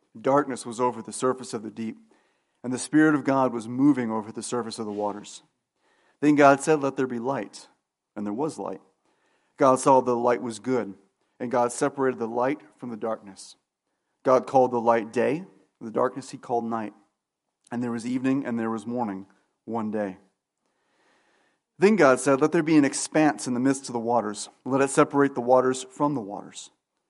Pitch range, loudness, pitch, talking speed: 115-135 Hz, -25 LUFS, 125 Hz, 200 wpm